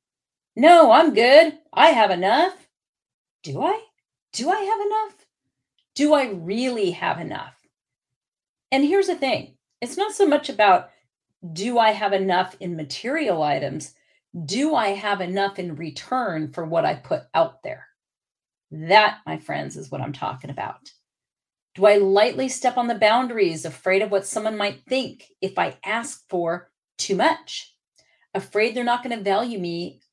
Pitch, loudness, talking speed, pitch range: 220 Hz, -21 LUFS, 155 wpm, 190-290 Hz